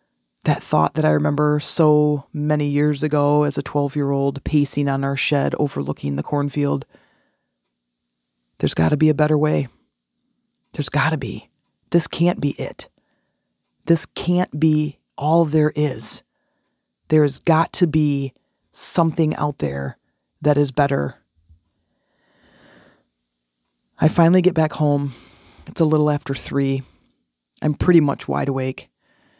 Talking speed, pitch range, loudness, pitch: 140 wpm, 100-150 Hz, -19 LUFS, 145 Hz